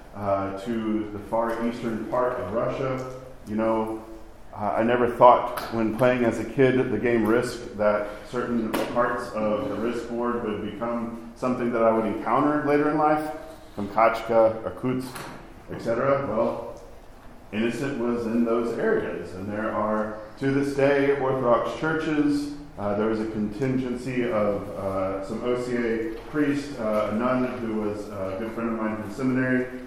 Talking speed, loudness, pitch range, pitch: 160 wpm, -25 LUFS, 110-125 Hz, 115 Hz